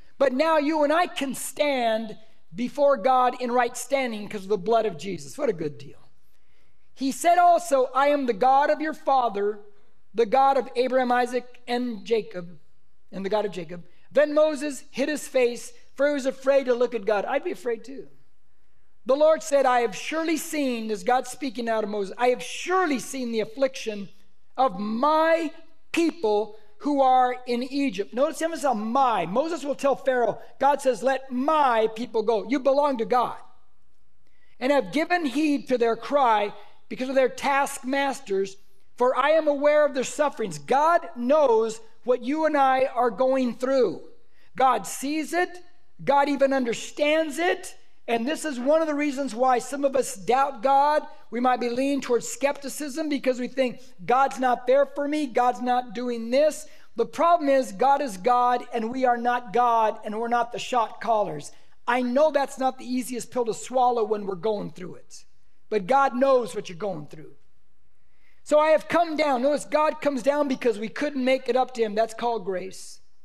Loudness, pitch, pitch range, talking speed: -24 LUFS, 255 Hz, 230-285 Hz, 190 wpm